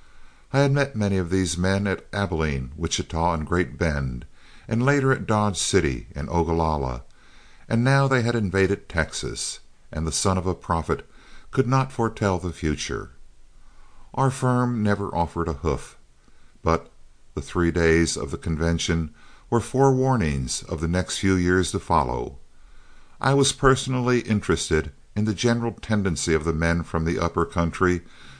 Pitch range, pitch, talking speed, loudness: 80-115 Hz, 90 Hz, 155 wpm, -24 LUFS